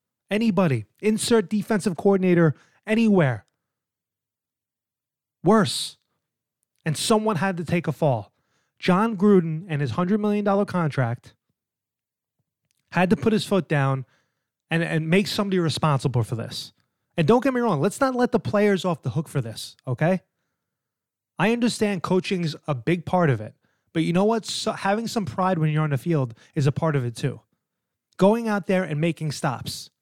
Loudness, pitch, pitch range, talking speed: -23 LUFS, 170 Hz, 145-205 Hz, 165 wpm